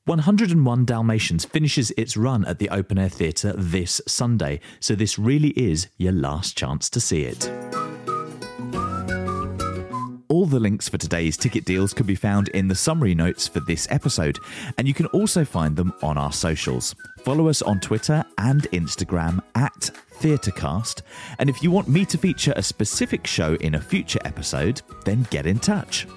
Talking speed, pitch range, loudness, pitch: 170 wpm, 90-135 Hz, -22 LUFS, 105 Hz